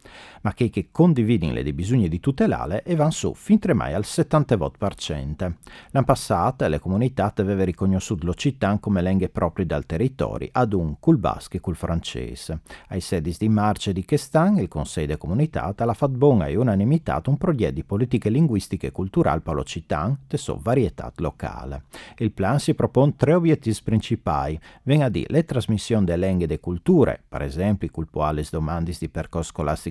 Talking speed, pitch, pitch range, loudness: 175 wpm, 100 Hz, 85-130 Hz, -23 LUFS